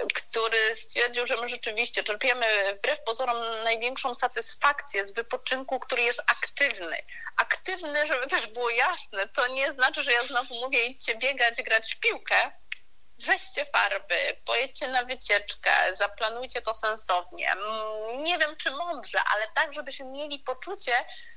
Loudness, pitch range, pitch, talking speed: -26 LUFS, 225-285 Hz, 245 Hz, 140 wpm